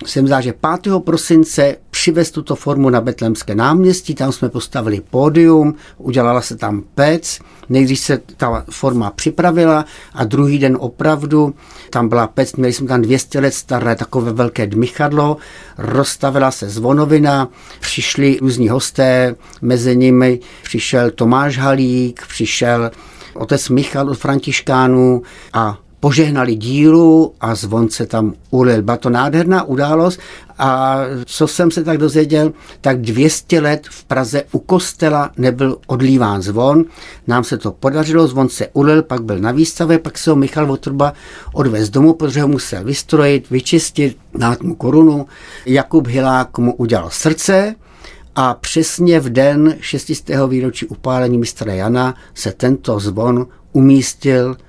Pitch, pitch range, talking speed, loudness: 135 Hz, 125-155 Hz, 140 wpm, -14 LUFS